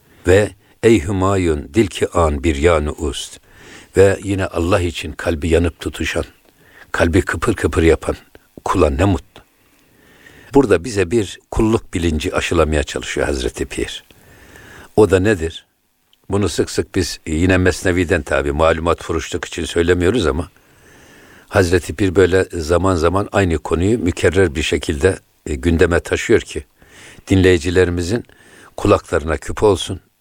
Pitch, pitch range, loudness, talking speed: 90 Hz, 85-100 Hz, -17 LUFS, 125 wpm